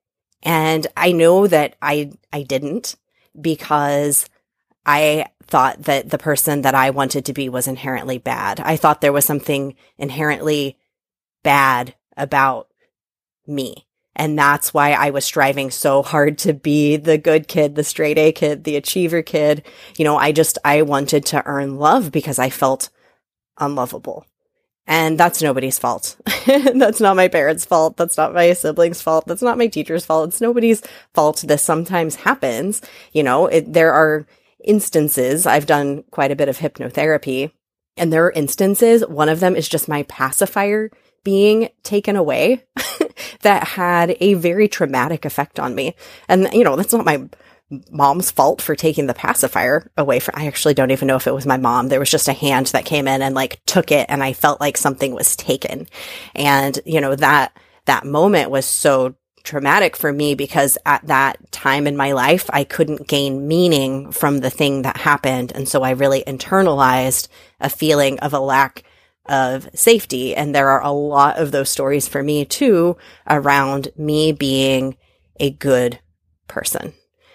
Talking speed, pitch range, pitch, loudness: 170 wpm, 140-165 Hz, 150 Hz, -16 LUFS